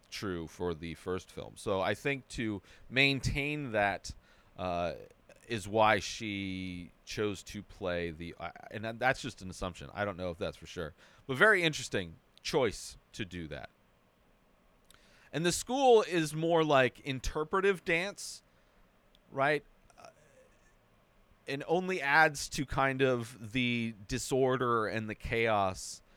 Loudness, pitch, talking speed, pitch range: -32 LUFS, 115 Hz, 135 wpm, 95-135 Hz